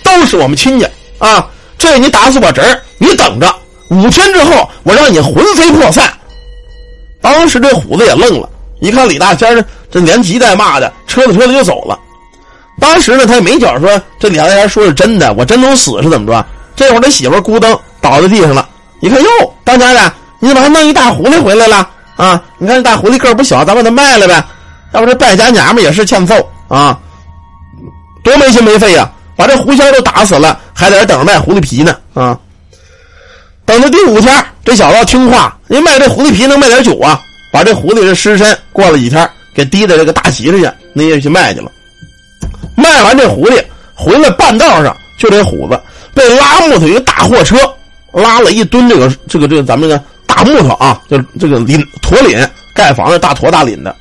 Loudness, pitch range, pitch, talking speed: -6 LUFS, 160-265 Hz, 225 Hz, 300 characters per minute